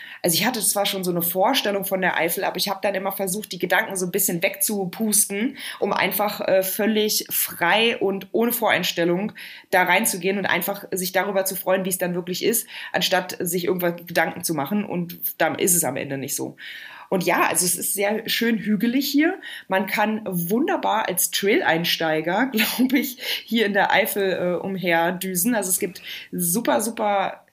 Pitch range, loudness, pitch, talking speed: 180-215 Hz, -21 LUFS, 195 Hz, 185 wpm